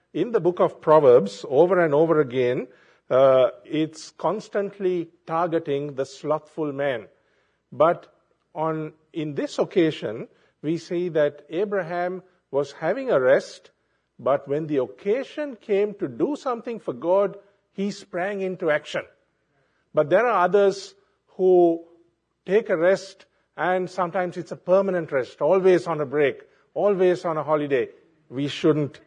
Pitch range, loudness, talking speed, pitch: 155-195 Hz, -23 LUFS, 140 wpm, 175 Hz